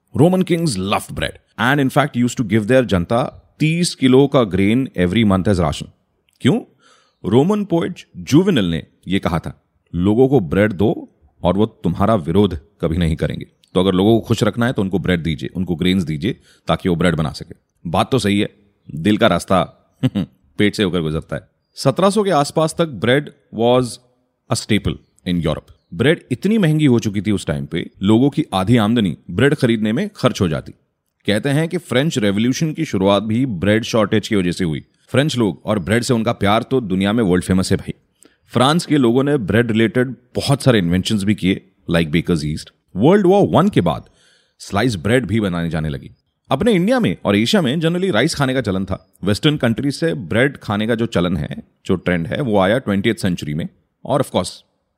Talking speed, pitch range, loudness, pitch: 200 wpm, 95-135 Hz, -17 LUFS, 110 Hz